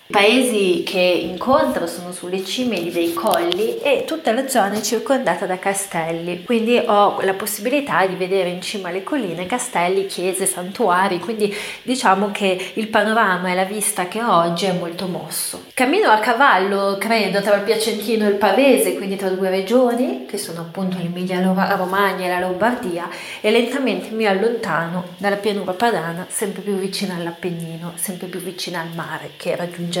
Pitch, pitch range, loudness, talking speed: 195 Hz, 180-225 Hz, -19 LUFS, 165 wpm